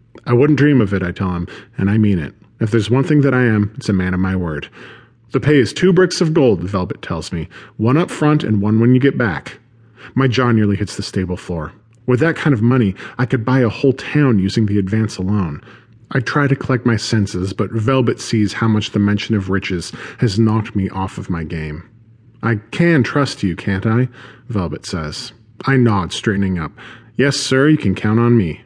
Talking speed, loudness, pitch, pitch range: 225 wpm, -17 LUFS, 115 Hz, 100-130 Hz